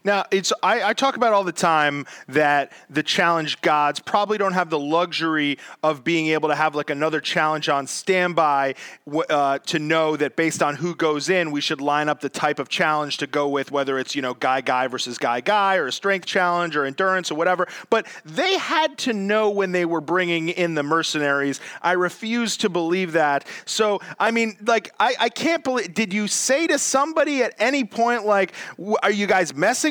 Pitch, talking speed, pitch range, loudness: 170 Hz, 205 wpm, 150-205 Hz, -21 LUFS